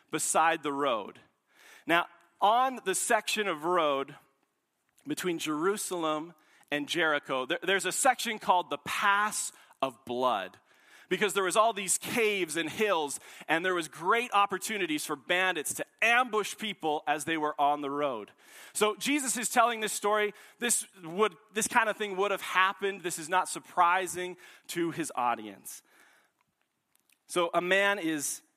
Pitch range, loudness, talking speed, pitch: 155-210 Hz, -29 LUFS, 150 wpm, 185 Hz